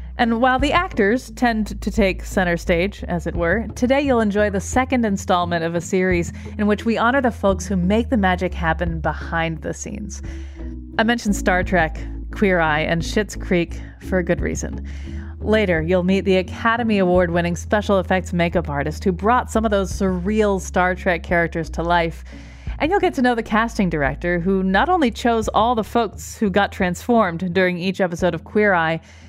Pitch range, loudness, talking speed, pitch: 175-220 Hz, -20 LUFS, 195 wpm, 190 Hz